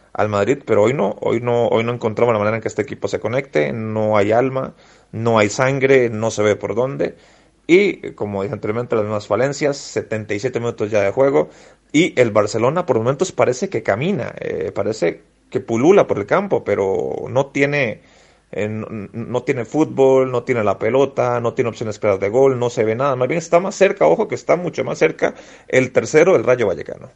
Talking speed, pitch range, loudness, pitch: 210 wpm, 110-145 Hz, -18 LUFS, 120 Hz